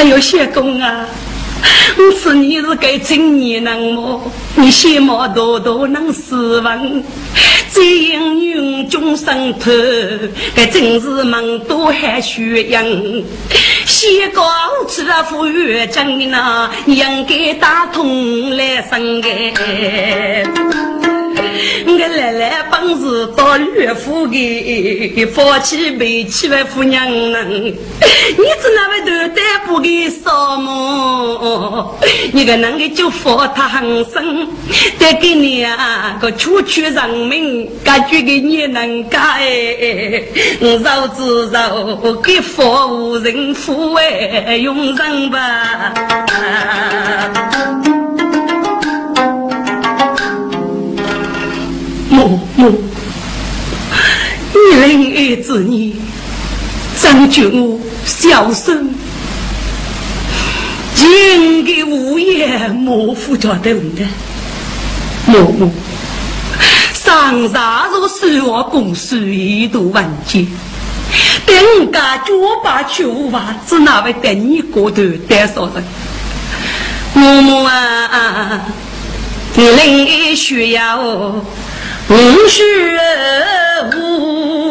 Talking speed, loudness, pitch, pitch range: 115 characters per minute, -11 LUFS, 265 Hz, 230-310 Hz